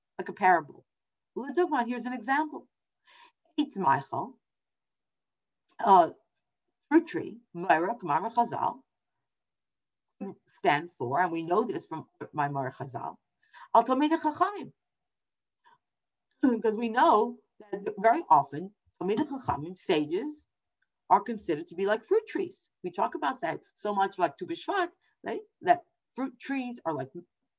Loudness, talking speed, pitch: -29 LUFS, 100 wpm, 245 Hz